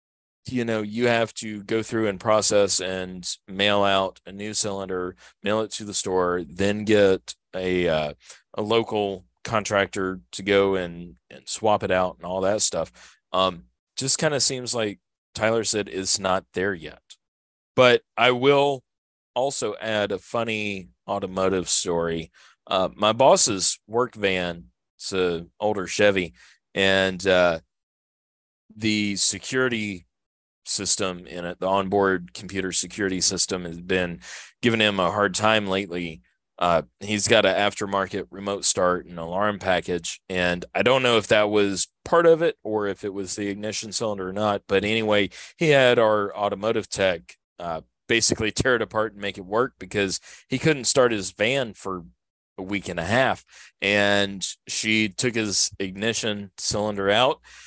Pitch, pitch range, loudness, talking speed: 100 Hz, 90-110 Hz, -23 LUFS, 155 wpm